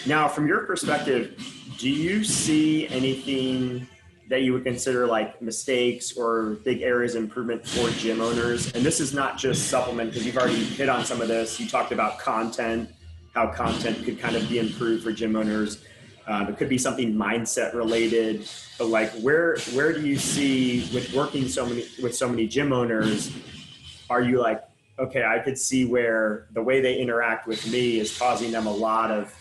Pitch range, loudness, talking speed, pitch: 110-130 Hz, -25 LUFS, 190 wpm, 120 Hz